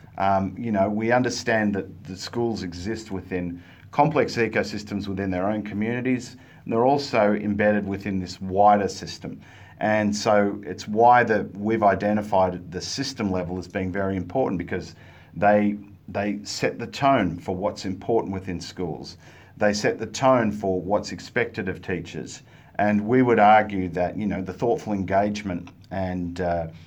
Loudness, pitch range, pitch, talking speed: -24 LUFS, 95-110 Hz, 100 Hz, 155 wpm